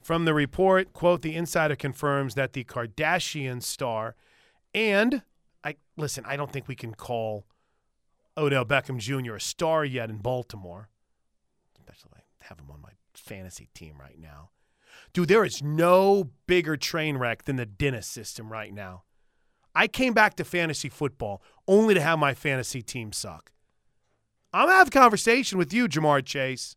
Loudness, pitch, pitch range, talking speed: -25 LUFS, 140 Hz, 110-170 Hz, 165 wpm